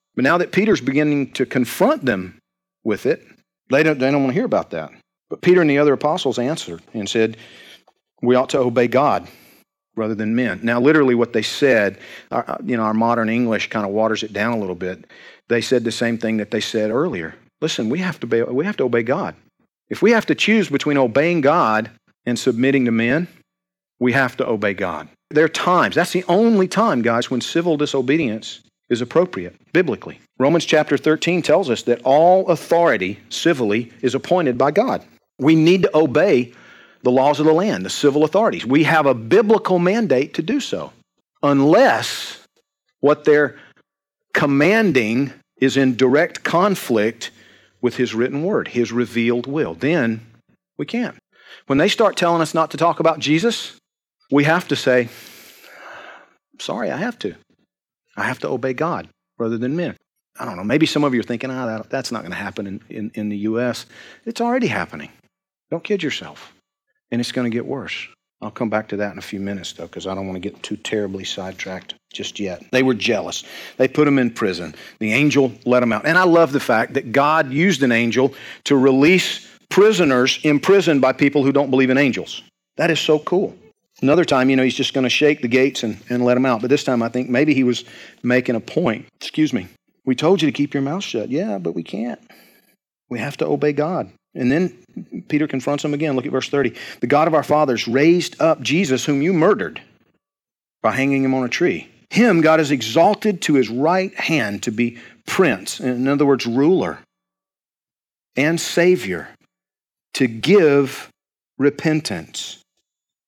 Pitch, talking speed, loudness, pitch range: 135 Hz, 195 wpm, -18 LUFS, 120-160 Hz